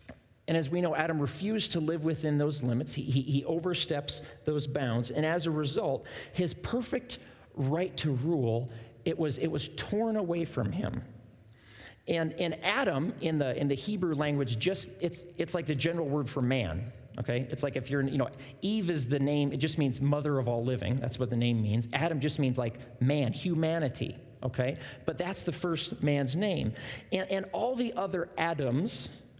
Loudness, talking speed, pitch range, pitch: -31 LUFS, 190 wpm, 125-170 Hz, 145 Hz